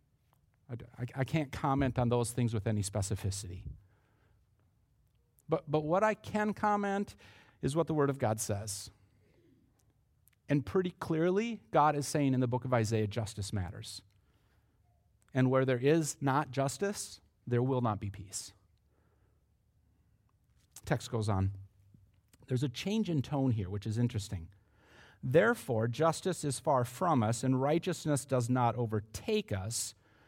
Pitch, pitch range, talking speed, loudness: 120 Hz, 105-140 Hz, 140 wpm, -33 LUFS